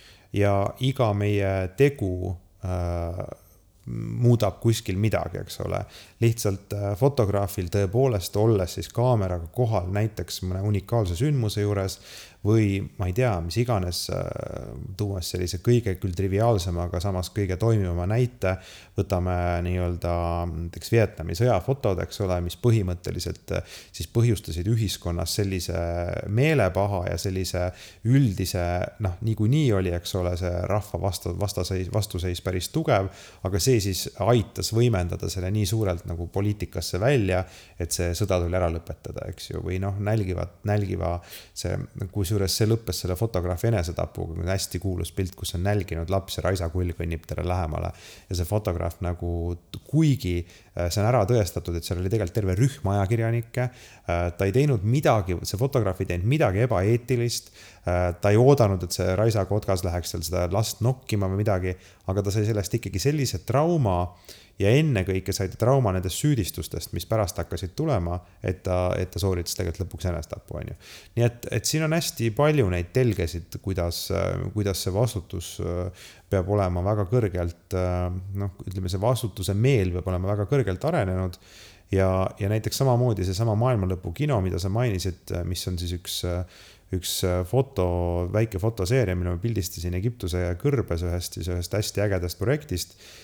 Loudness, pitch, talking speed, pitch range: -26 LUFS, 95 Hz, 150 wpm, 90-110 Hz